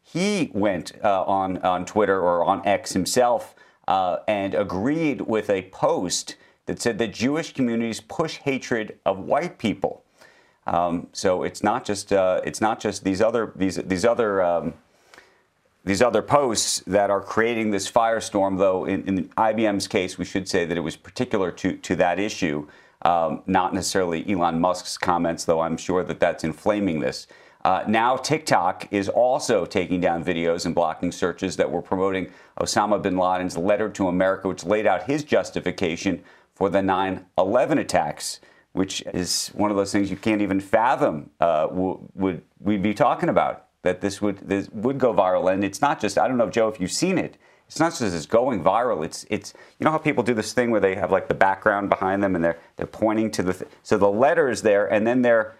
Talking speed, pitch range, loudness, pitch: 195 wpm, 90-110 Hz, -23 LUFS, 95 Hz